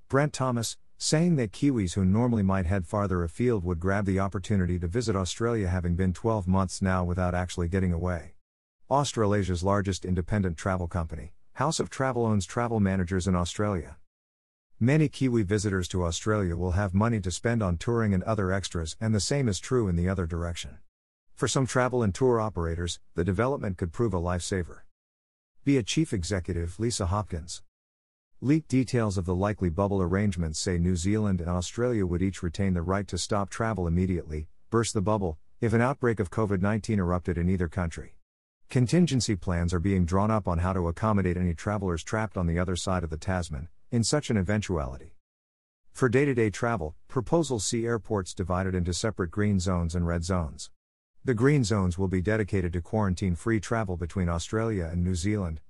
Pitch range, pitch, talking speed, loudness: 90-110 Hz, 95 Hz, 185 wpm, -28 LUFS